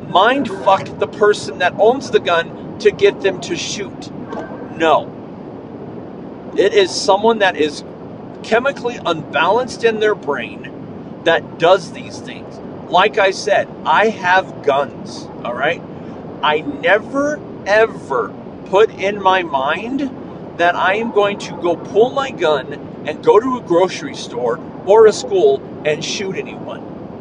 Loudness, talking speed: -16 LUFS, 140 wpm